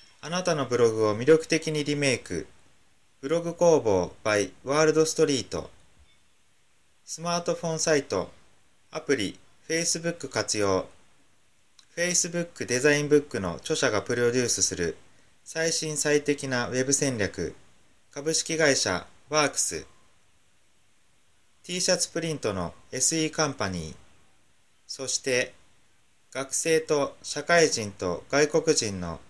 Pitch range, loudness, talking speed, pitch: 120-160 Hz, -26 LUFS, 265 characters per minute, 145 Hz